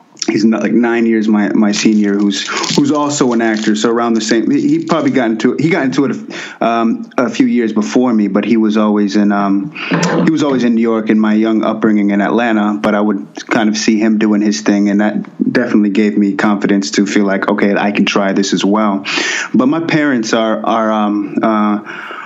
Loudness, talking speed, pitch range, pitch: -13 LUFS, 225 wpm, 105-115 Hz, 105 Hz